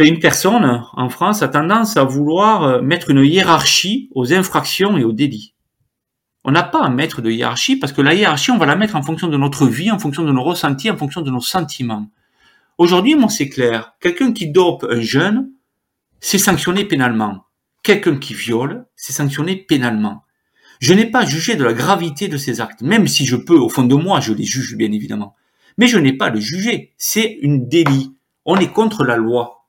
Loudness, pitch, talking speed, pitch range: -15 LUFS, 150 Hz, 205 wpm, 125-190 Hz